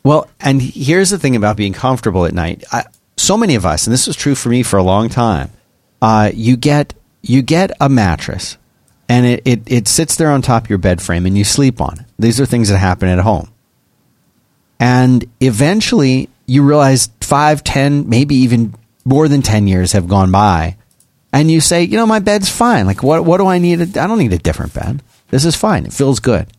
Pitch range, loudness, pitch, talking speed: 105-145 Hz, -12 LUFS, 125 Hz, 220 wpm